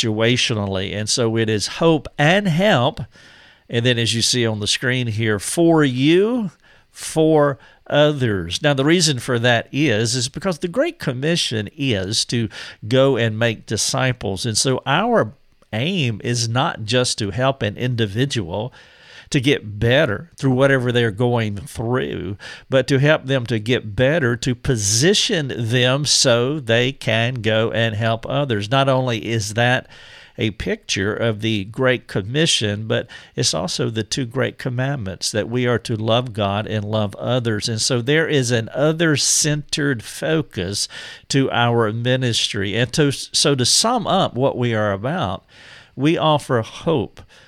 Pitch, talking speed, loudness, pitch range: 125 Hz, 155 wpm, -19 LUFS, 115-140 Hz